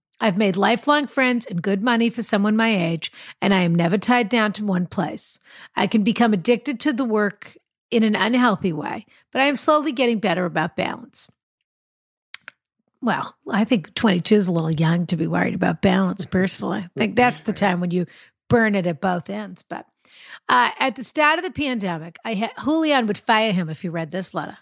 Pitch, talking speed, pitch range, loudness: 215 Hz, 205 wpm, 180-240 Hz, -21 LUFS